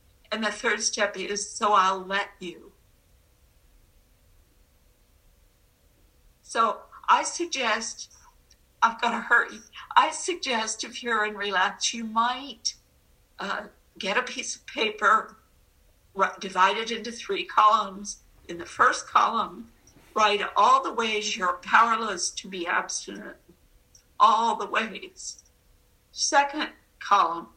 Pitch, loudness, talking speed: 205 Hz, -25 LUFS, 120 wpm